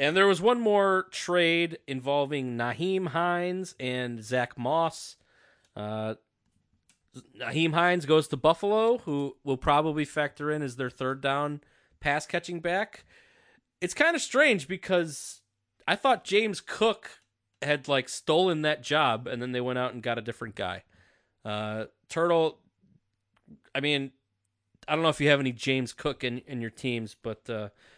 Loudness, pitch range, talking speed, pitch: -28 LUFS, 125-175 Hz, 155 wpm, 145 Hz